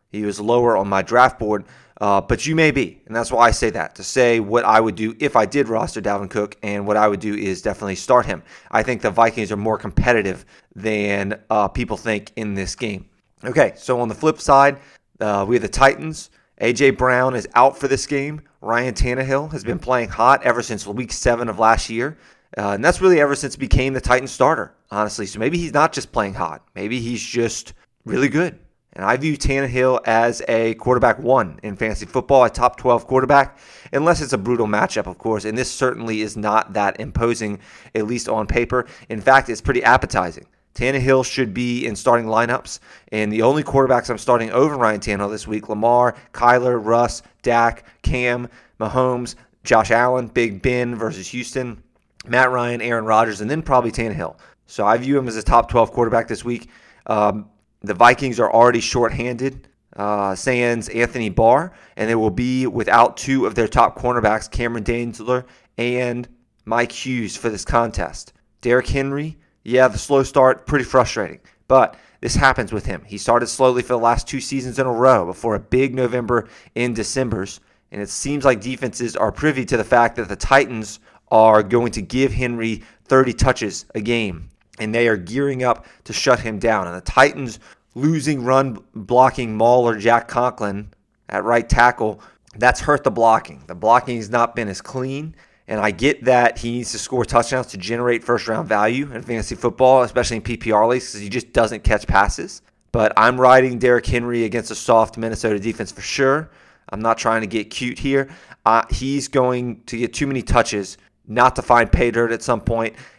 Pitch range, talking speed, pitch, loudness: 110-130 Hz, 195 wpm, 120 Hz, -18 LUFS